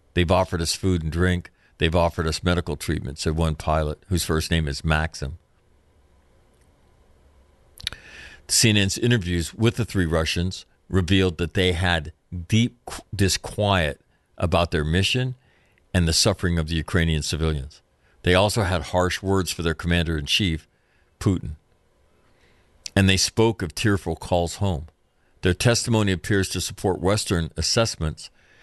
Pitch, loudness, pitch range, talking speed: 90 Hz, -23 LUFS, 80-95 Hz, 140 wpm